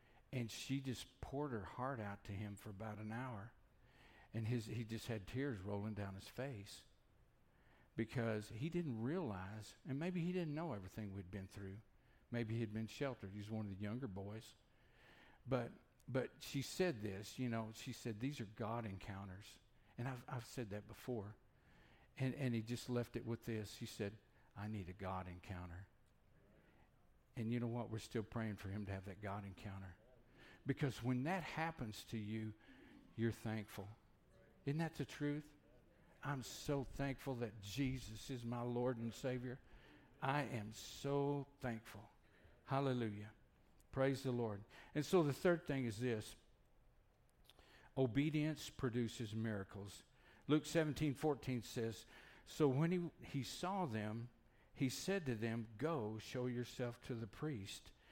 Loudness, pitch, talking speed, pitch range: -45 LUFS, 115 Hz, 160 wpm, 105-135 Hz